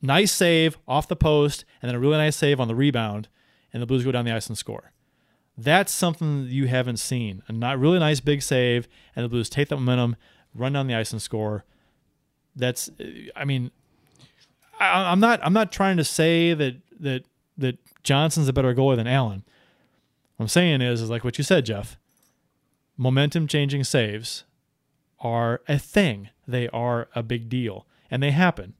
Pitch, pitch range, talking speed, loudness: 135 Hz, 120-150 Hz, 190 wpm, -23 LUFS